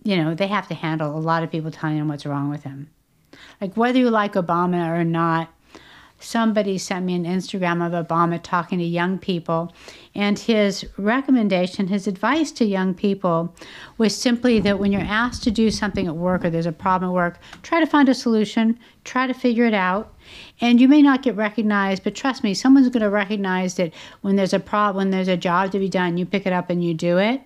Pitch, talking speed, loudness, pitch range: 195 Hz, 225 wpm, -20 LUFS, 175-220 Hz